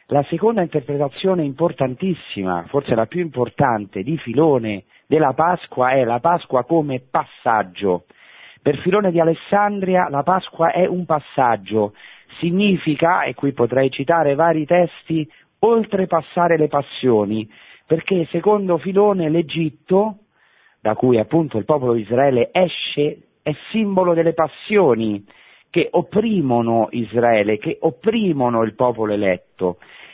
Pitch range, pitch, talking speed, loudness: 120-175 Hz, 155 Hz, 120 wpm, -19 LUFS